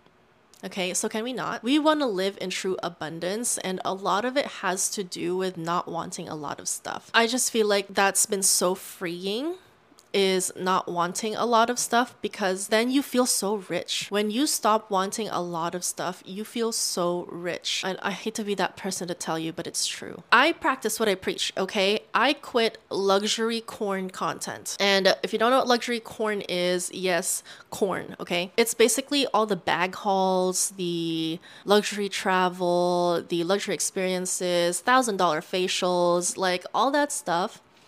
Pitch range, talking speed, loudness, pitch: 180-225 Hz, 180 wpm, -25 LUFS, 195 Hz